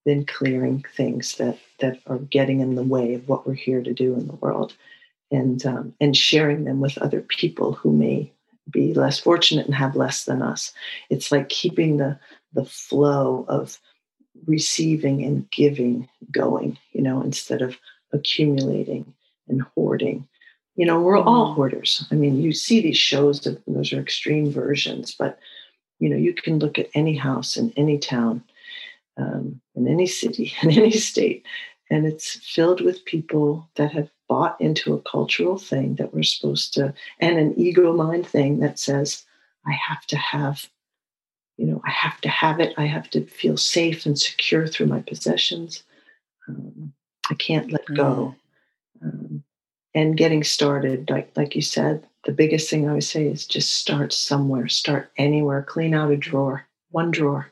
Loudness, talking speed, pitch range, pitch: -21 LUFS, 170 wpm, 135-160 Hz, 145 Hz